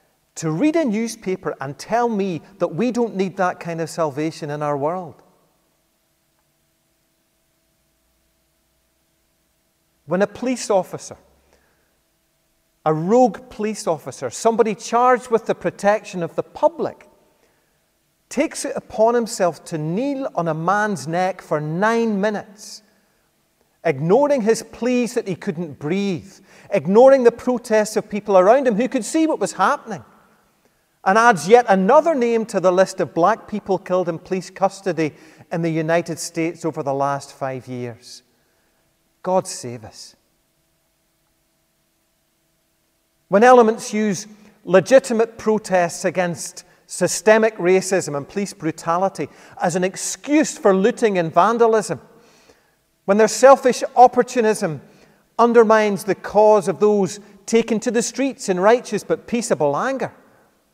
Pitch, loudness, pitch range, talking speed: 195 Hz, -19 LUFS, 170-230 Hz, 130 wpm